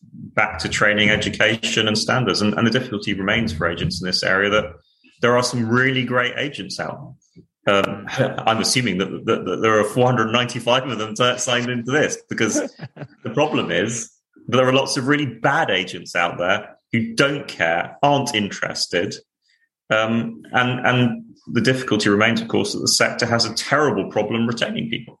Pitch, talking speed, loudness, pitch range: 120 Hz, 180 wpm, -19 LUFS, 110-130 Hz